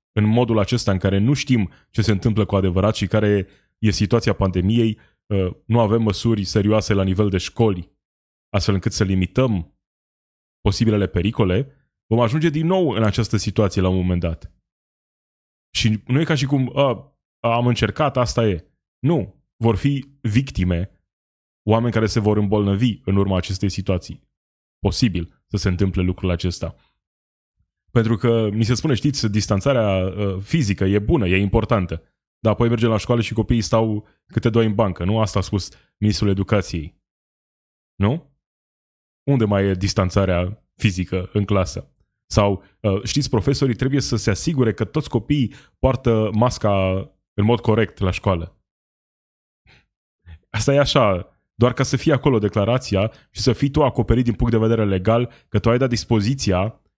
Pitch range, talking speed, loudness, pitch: 95-120 Hz, 160 wpm, -20 LUFS, 105 Hz